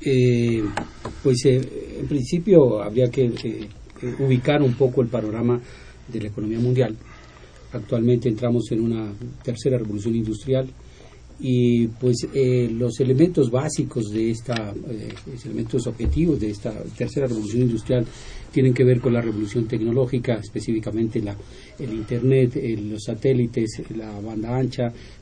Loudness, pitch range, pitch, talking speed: -22 LUFS, 110-130 Hz, 120 Hz, 140 wpm